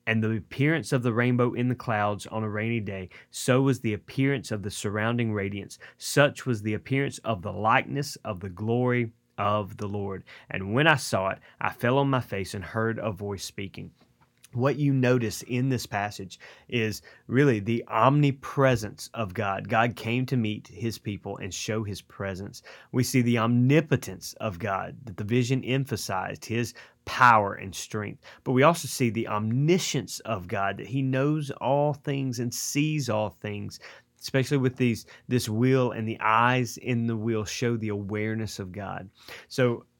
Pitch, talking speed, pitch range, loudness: 115 Hz, 180 wpm, 105-130 Hz, -27 LUFS